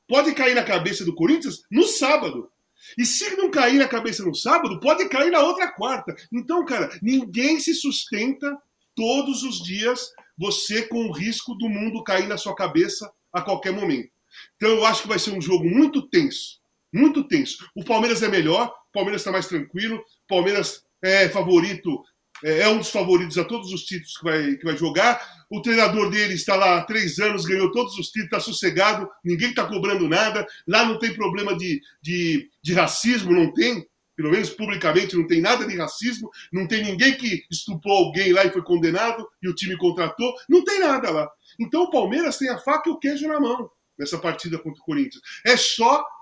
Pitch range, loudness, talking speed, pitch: 185-265 Hz, -21 LUFS, 195 wpm, 220 Hz